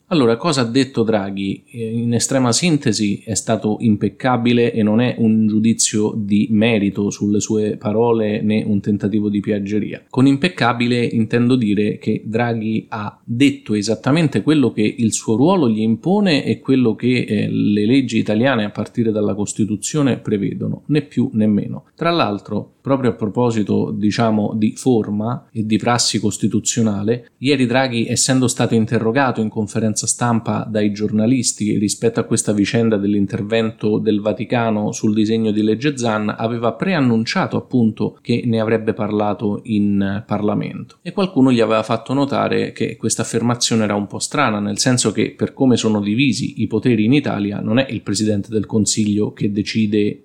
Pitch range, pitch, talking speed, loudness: 105-120 Hz, 110 Hz, 160 wpm, -18 LUFS